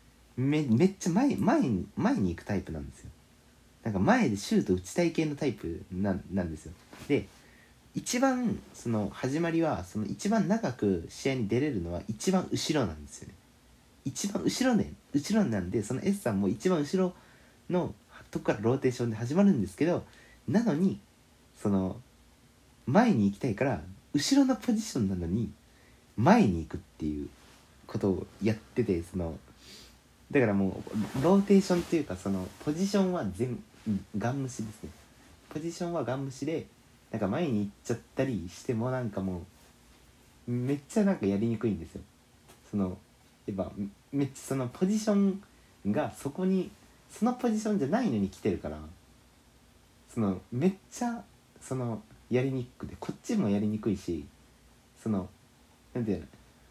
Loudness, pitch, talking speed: -30 LUFS, 120 Hz, 320 characters per minute